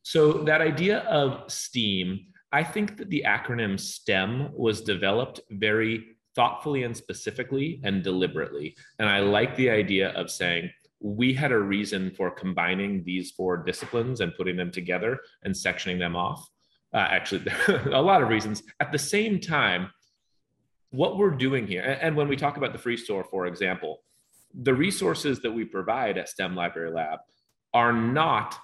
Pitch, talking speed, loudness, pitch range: 115 Hz, 165 wpm, -26 LUFS, 95-140 Hz